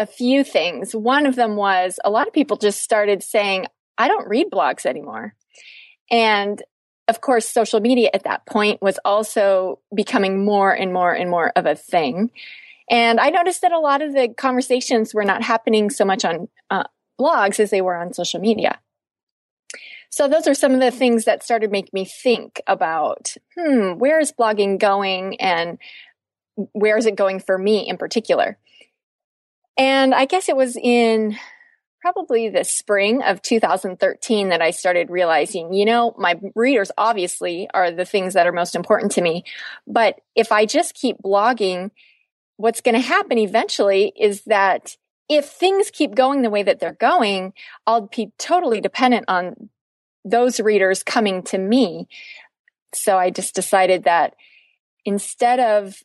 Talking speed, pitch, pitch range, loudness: 165 wpm, 215 Hz, 195-250 Hz, -18 LUFS